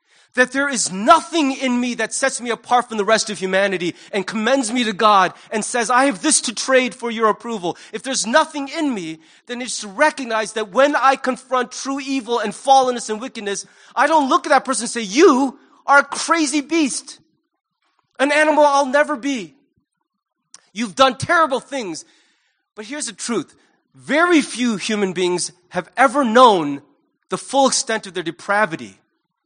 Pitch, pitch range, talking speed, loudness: 250 Hz, 215-280 Hz, 180 wpm, -18 LUFS